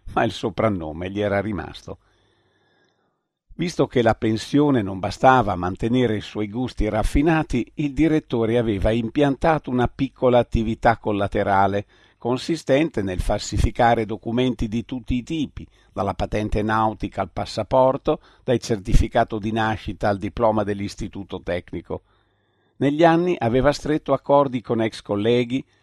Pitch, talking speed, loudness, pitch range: 115 Hz, 130 wpm, -22 LUFS, 105-130 Hz